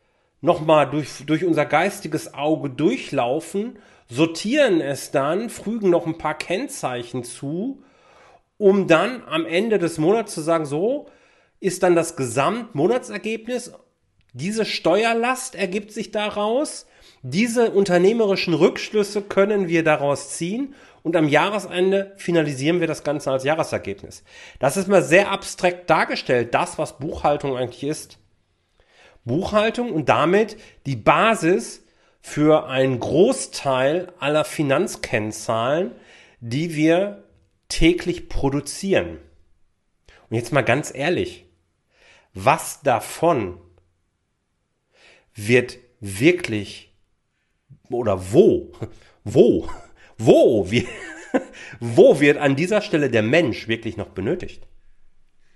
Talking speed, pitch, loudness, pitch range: 105 wpm, 160 Hz, -20 LUFS, 125-195 Hz